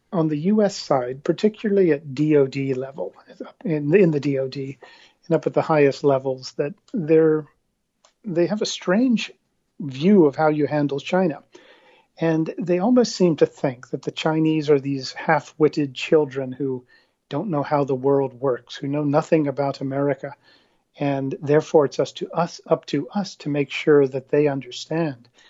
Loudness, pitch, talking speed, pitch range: -21 LUFS, 150 Hz, 165 wpm, 140-170 Hz